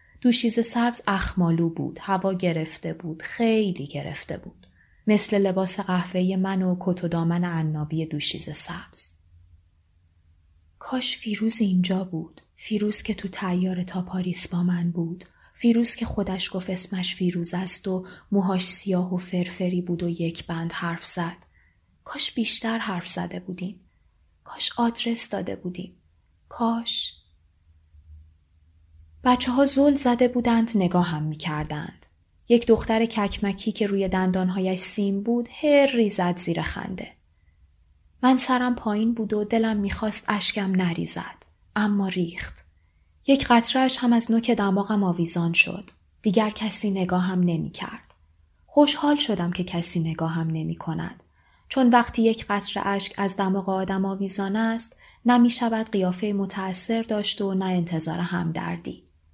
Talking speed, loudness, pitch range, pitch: 140 wpm, -22 LUFS, 165-215 Hz, 185 Hz